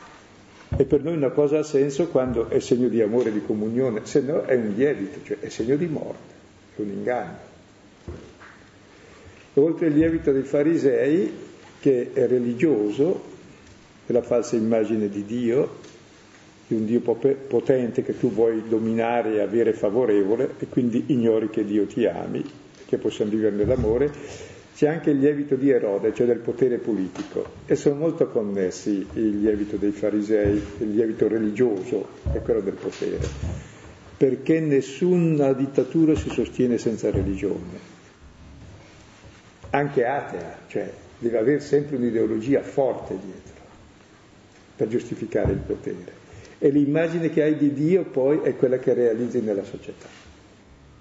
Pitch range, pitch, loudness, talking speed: 105-145 Hz, 120 Hz, -23 LUFS, 145 wpm